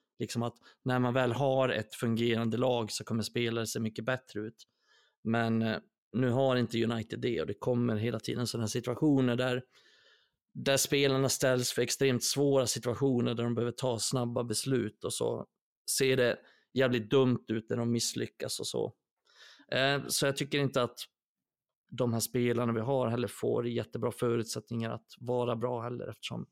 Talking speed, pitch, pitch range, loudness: 165 wpm, 120 Hz, 115-130 Hz, -31 LUFS